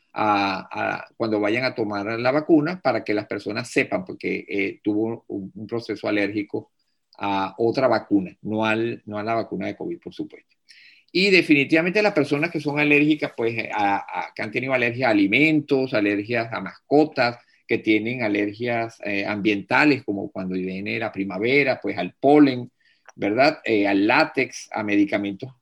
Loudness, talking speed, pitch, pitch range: -22 LUFS, 165 wpm, 115 Hz, 105-145 Hz